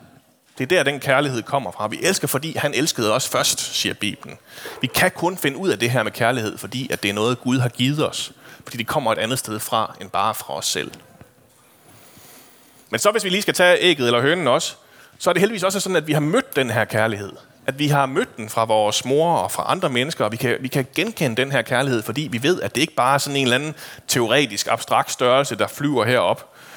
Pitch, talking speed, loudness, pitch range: 130 Hz, 245 wpm, -20 LUFS, 115-150 Hz